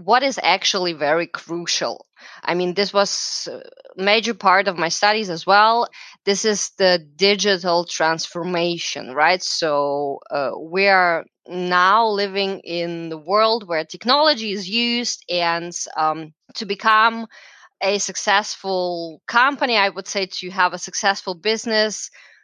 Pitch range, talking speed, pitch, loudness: 170-215 Hz, 135 wpm, 195 Hz, -19 LUFS